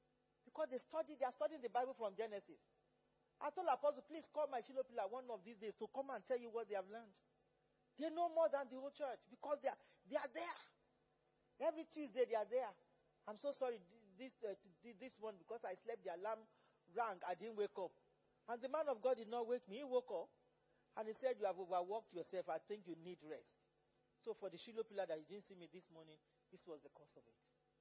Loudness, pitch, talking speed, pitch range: -47 LUFS, 230 Hz, 230 wpm, 200-265 Hz